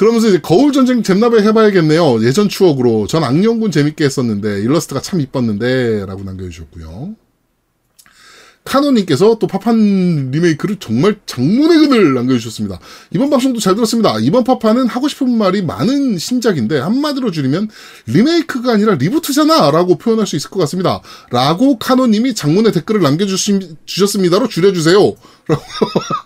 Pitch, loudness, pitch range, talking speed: 200 Hz, -13 LUFS, 150-235 Hz, 385 characters per minute